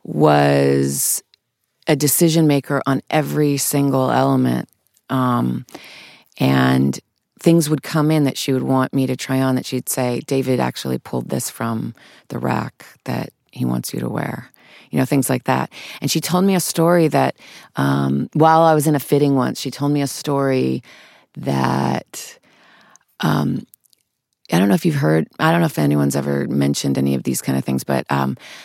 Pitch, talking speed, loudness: 130 Hz, 180 wpm, -18 LUFS